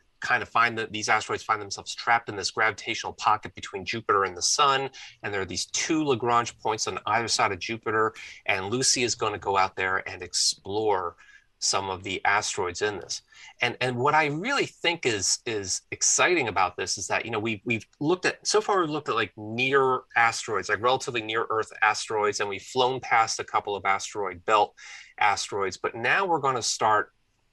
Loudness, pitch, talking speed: -25 LUFS, 140 Hz, 205 wpm